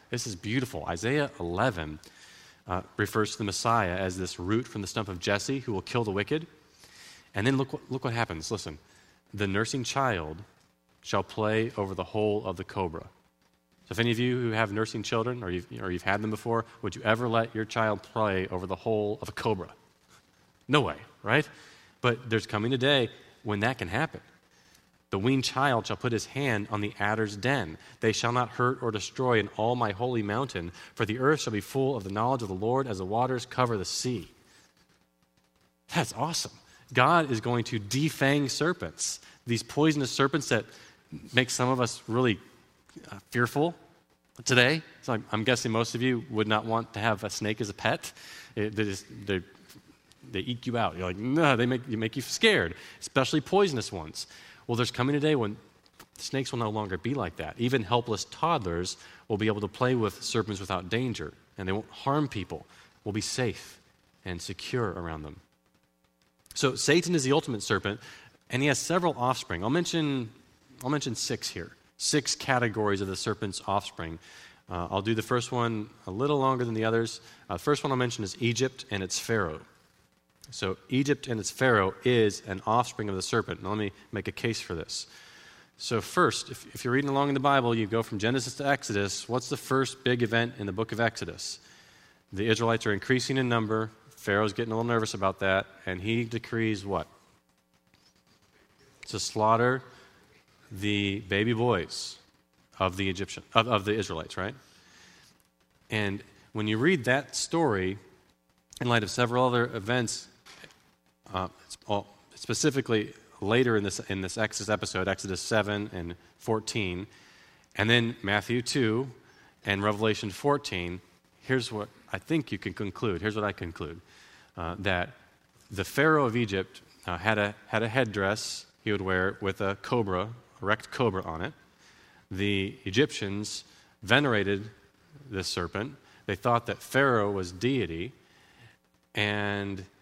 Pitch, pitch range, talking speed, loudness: 110 Hz, 95-125 Hz, 180 wpm, -29 LUFS